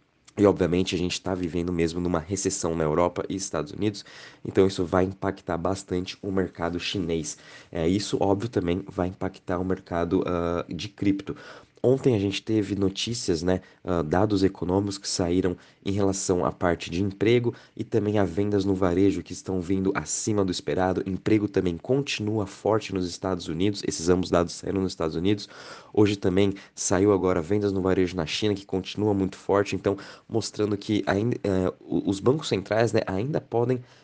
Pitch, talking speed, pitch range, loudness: 95 Hz, 175 wpm, 90-100 Hz, -26 LUFS